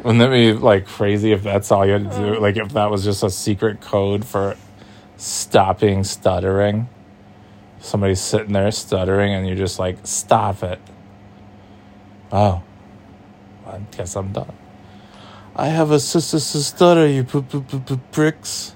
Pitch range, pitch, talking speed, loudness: 100-110 Hz, 105 Hz, 145 wpm, -18 LUFS